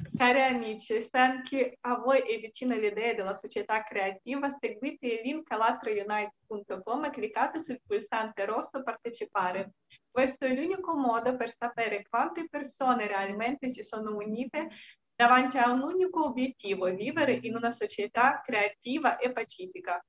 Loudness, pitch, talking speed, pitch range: -30 LUFS, 235 Hz, 135 wpm, 215-260 Hz